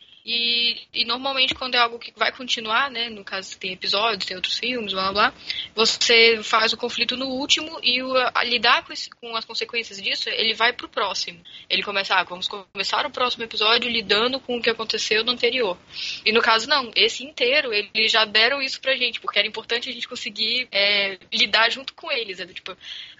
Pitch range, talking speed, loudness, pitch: 220-250 Hz, 210 wpm, -21 LUFS, 230 Hz